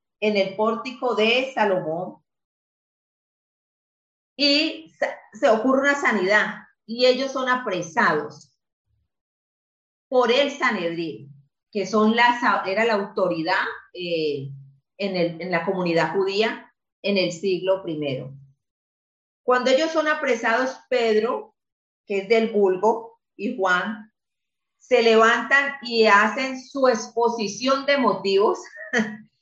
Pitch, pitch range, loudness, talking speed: 220 Hz, 185-250 Hz, -21 LUFS, 110 wpm